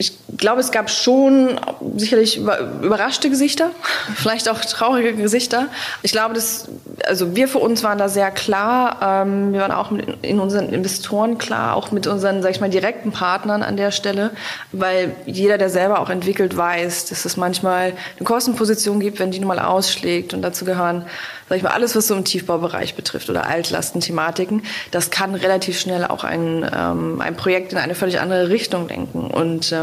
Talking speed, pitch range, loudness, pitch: 175 wpm, 185-220 Hz, -19 LUFS, 195 Hz